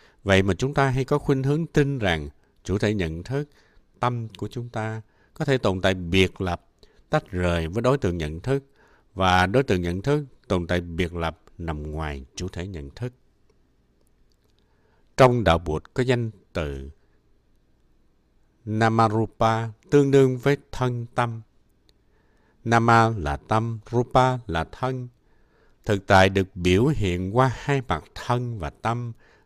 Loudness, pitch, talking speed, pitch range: -24 LUFS, 110 Hz, 155 wpm, 90-125 Hz